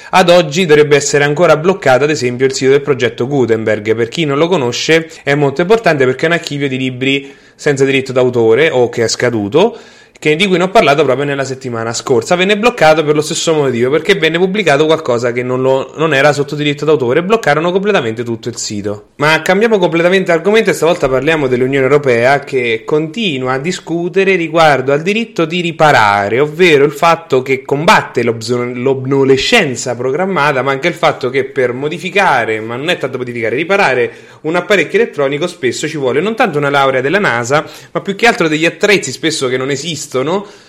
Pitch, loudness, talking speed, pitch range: 150 Hz, -12 LUFS, 185 wpm, 130-175 Hz